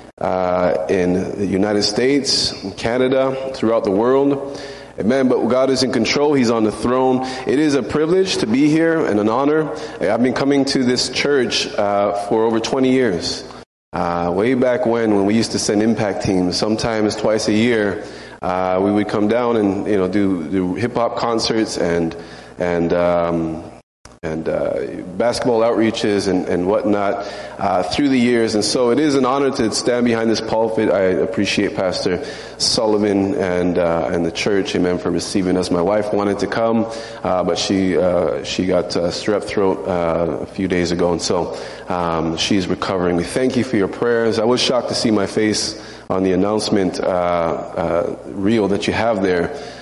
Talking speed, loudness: 185 wpm, -18 LUFS